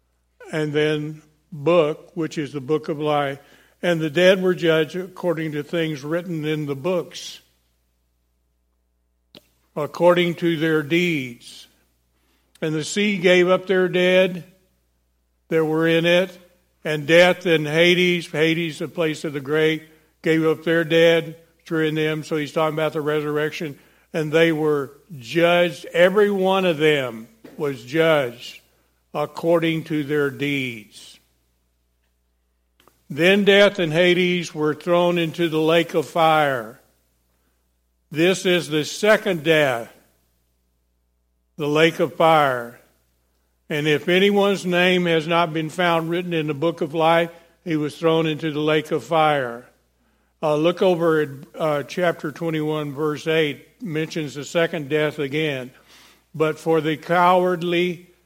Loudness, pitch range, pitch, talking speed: -20 LUFS, 140-170 Hz, 155 Hz, 135 wpm